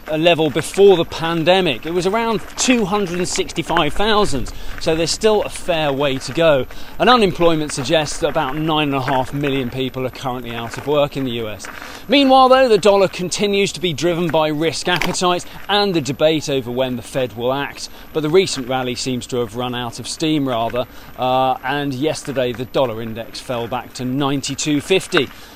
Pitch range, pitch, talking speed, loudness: 130-180 Hz, 150 Hz, 200 wpm, -18 LUFS